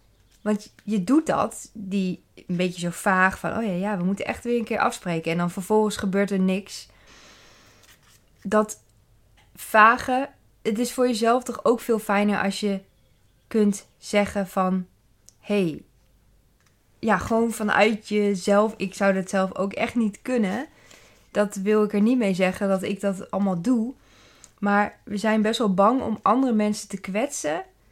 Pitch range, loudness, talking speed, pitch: 190-220 Hz, -24 LUFS, 165 wpm, 205 Hz